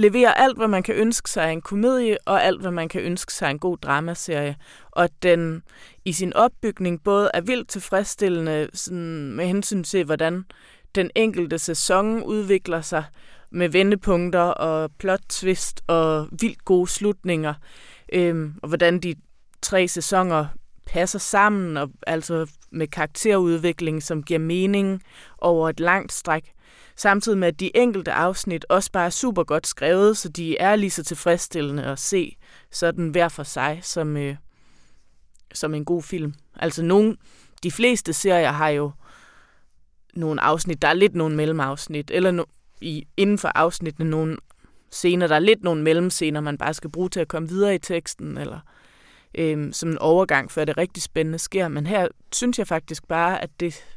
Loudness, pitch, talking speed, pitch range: -22 LUFS, 170 Hz, 170 wpm, 155-190 Hz